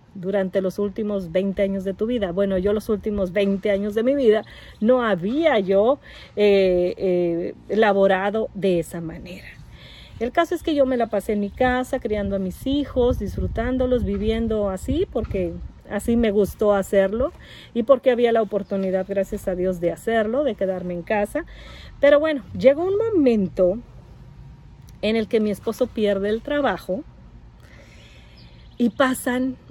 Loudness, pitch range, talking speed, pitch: -22 LUFS, 195-250 Hz, 160 wpm, 210 Hz